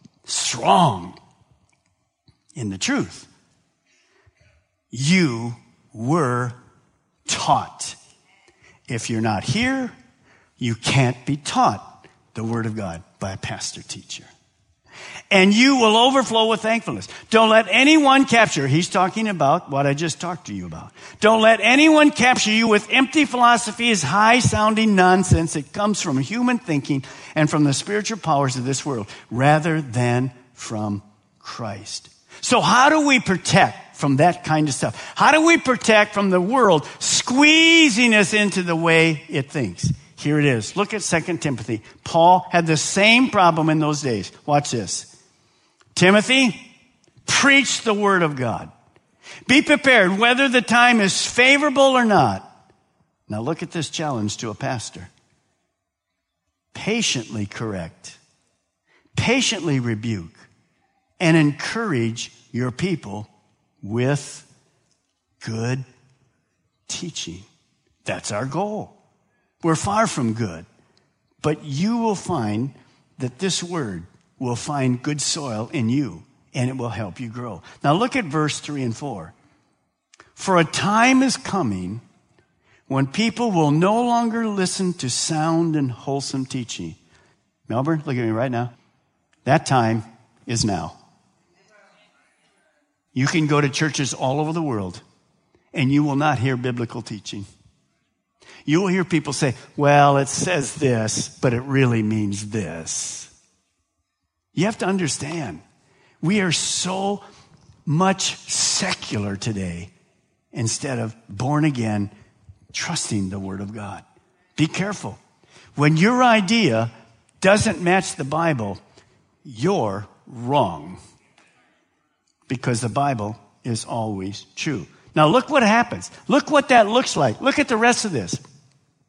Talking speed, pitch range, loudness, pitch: 135 wpm, 115-195 Hz, -19 LUFS, 145 Hz